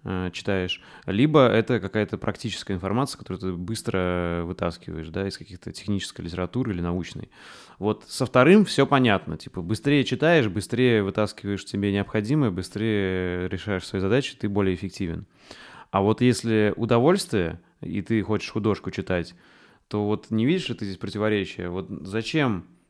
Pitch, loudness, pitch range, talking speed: 105 Hz, -24 LUFS, 95-115 Hz, 145 wpm